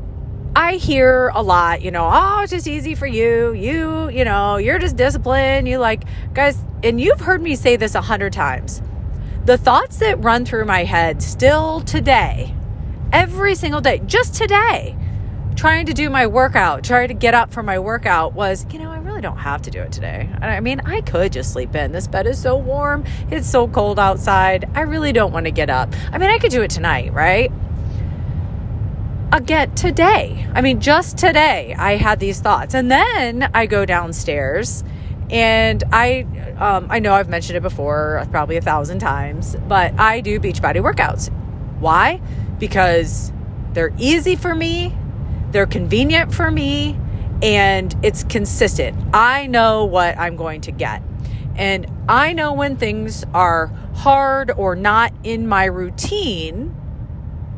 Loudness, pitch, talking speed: -16 LUFS, 195 Hz, 170 wpm